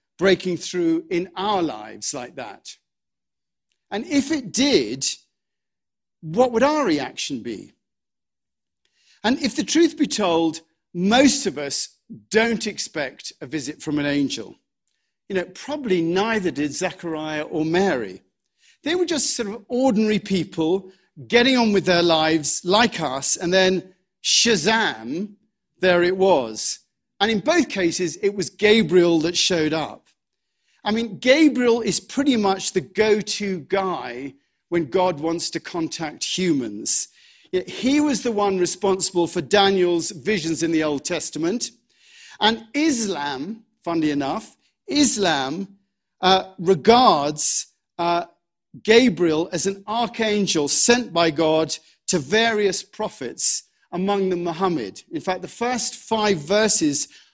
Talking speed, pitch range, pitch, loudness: 130 wpm, 170-230 Hz, 190 Hz, -21 LUFS